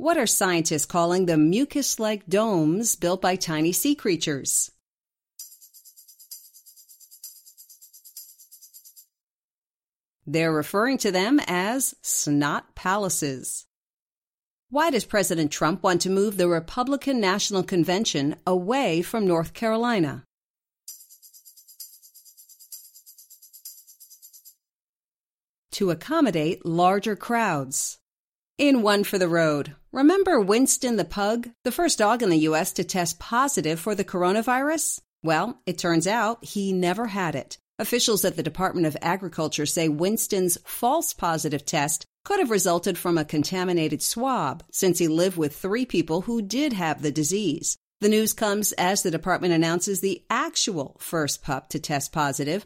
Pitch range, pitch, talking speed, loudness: 165-220 Hz, 185 Hz, 125 wpm, -24 LUFS